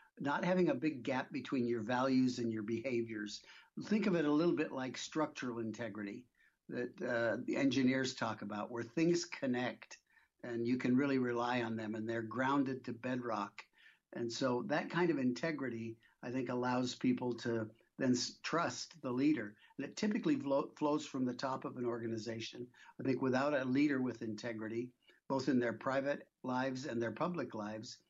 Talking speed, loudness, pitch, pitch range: 175 wpm, -37 LUFS, 125 Hz, 115-135 Hz